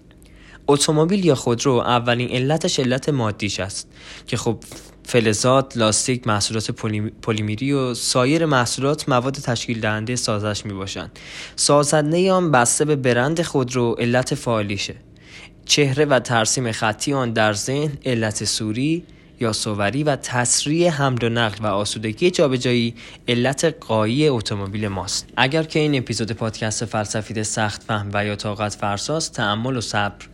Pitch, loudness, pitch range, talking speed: 120 Hz, -20 LUFS, 110-145 Hz, 135 wpm